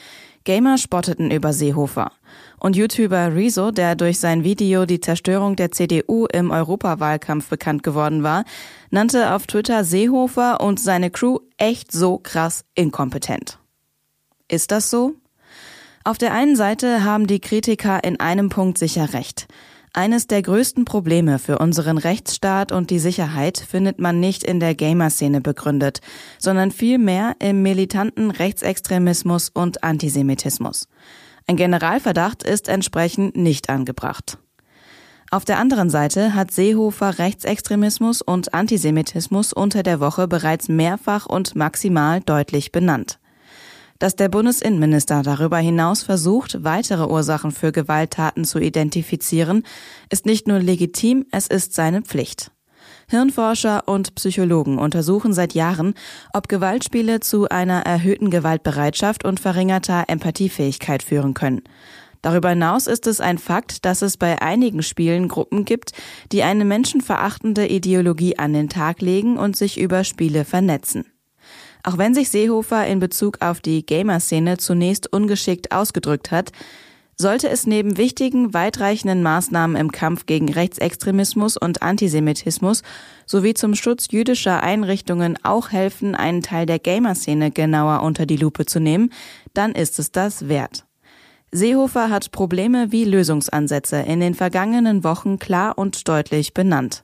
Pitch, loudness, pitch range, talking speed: 185 Hz, -19 LUFS, 165-205 Hz, 135 wpm